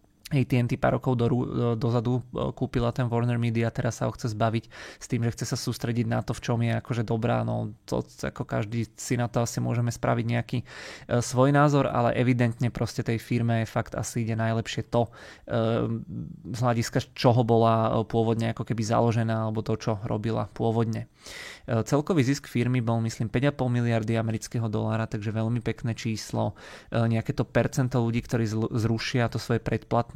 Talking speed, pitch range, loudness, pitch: 185 wpm, 115-125 Hz, -27 LUFS, 115 Hz